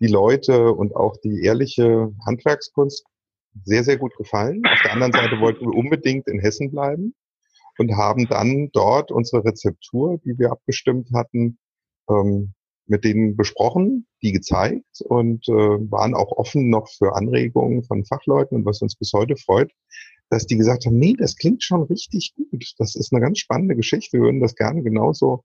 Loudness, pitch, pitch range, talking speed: -19 LUFS, 120 Hz, 105-140 Hz, 170 wpm